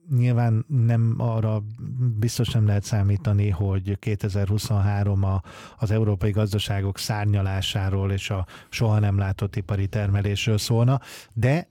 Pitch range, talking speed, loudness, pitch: 100-115 Hz, 120 wpm, -24 LUFS, 105 Hz